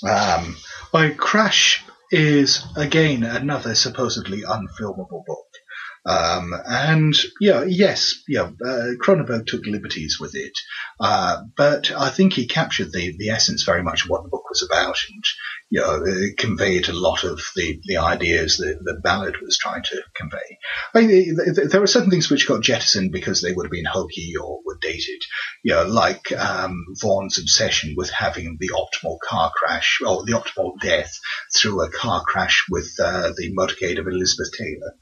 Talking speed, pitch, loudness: 180 wpm, 145 Hz, -20 LUFS